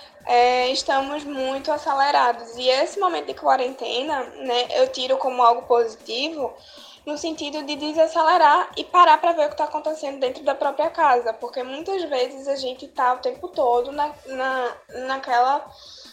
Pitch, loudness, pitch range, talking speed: 275 Hz, -21 LUFS, 250-300 Hz, 160 wpm